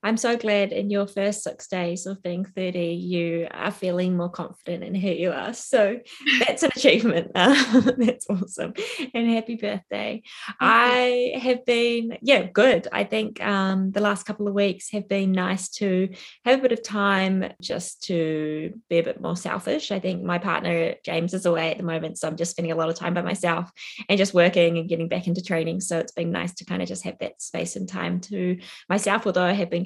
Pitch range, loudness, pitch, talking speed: 175-210 Hz, -23 LUFS, 190 Hz, 215 wpm